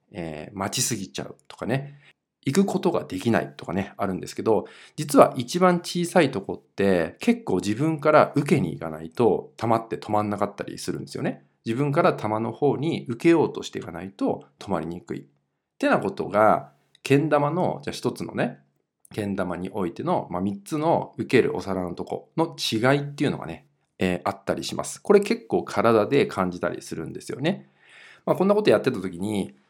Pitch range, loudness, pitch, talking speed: 95-155 Hz, -24 LUFS, 115 Hz, 375 characters per minute